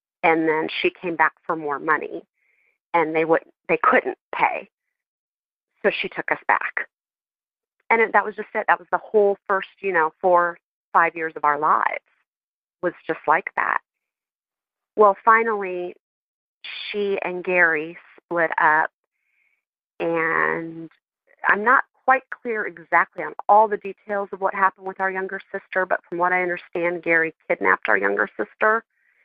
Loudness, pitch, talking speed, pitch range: -21 LUFS, 180 Hz, 155 wpm, 165-205 Hz